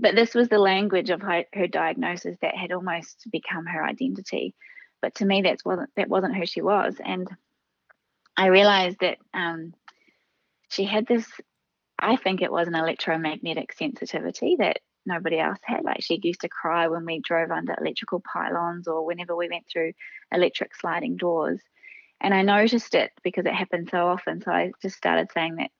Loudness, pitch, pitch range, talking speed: -25 LUFS, 180 Hz, 170-195 Hz, 180 wpm